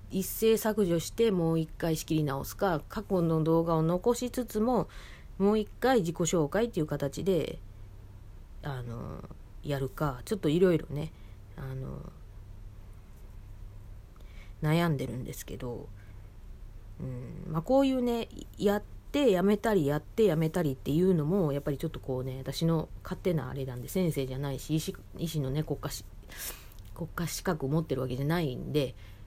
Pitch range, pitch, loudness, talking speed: 125-180 Hz, 150 Hz, -30 LUFS, 305 characters per minute